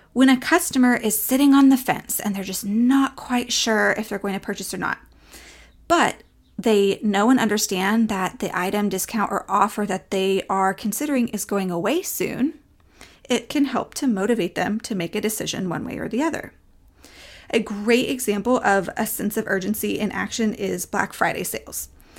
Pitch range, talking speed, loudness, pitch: 195-245 Hz, 185 wpm, -22 LUFS, 210 Hz